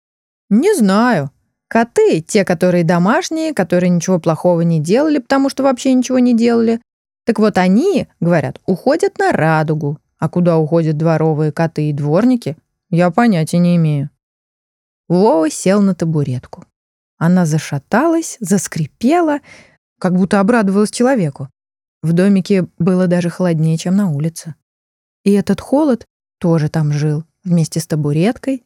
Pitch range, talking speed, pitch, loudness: 160-220 Hz, 130 wpm, 180 Hz, -15 LUFS